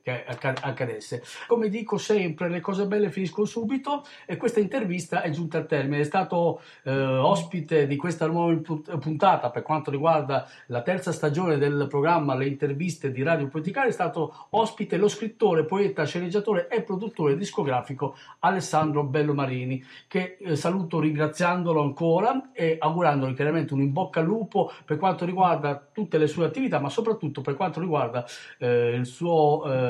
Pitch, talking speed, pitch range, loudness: 160 Hz, 160 wpm, 145-190 Hz, -26 LUFS